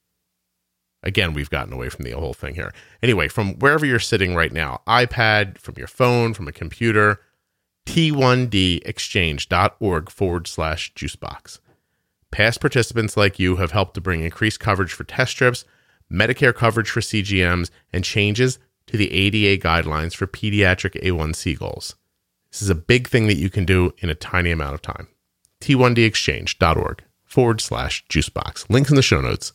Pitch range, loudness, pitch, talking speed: 85-115 Hz, -19 LUFS, 100 Hz, 160 wpm